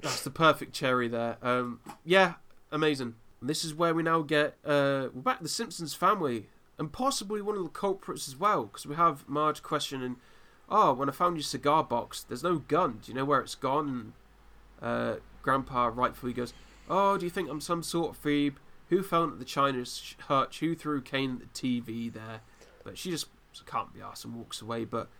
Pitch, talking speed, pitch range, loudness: 140 Hz, 205 wpm, 125-165 Hz, -30 LUFS